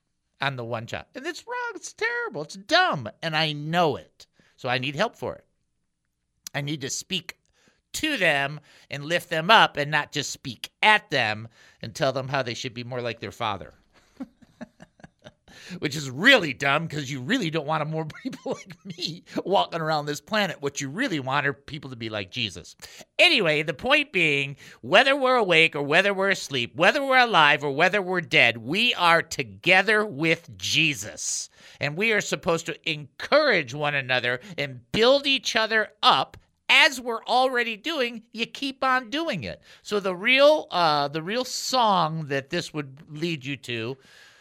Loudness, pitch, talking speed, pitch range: -23 LUFS, 160 Hz, 180 wpm, 140-220 Hz